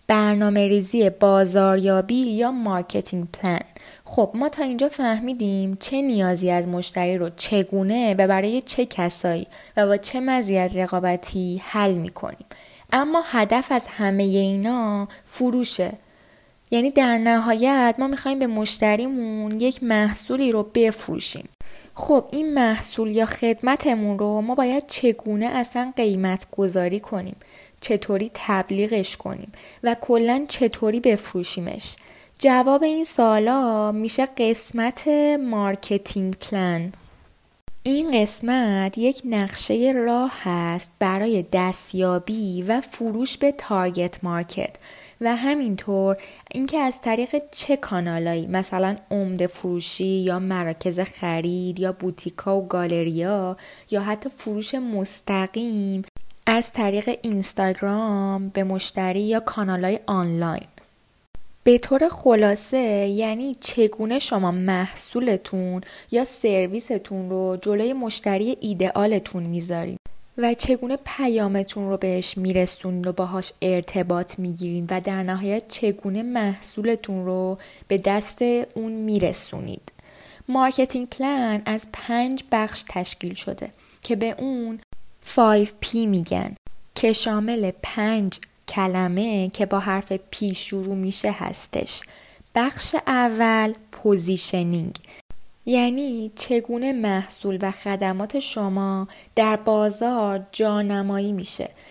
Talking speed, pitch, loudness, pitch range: 110 wpm, 210 Hz, -22 LUFS, 190-235 Hz